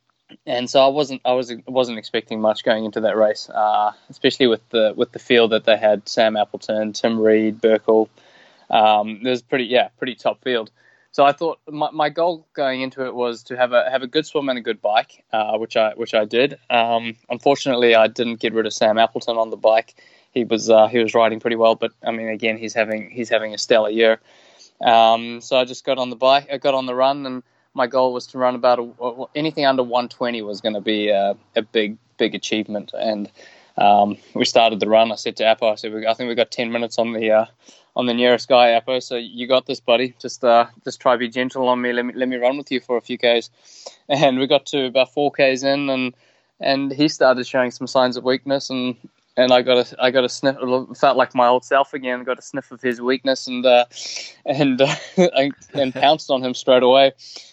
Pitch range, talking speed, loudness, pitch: 115-130 Hz, 235 wpm, -19 LUFS, 125 Hz